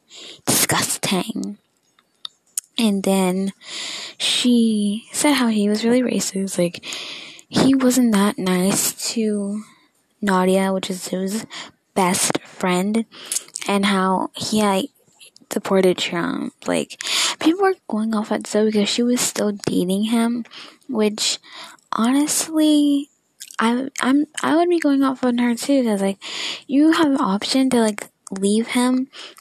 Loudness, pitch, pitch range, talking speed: -20 LUFS, 225 Hz, 200-265 Hz, 130 wpm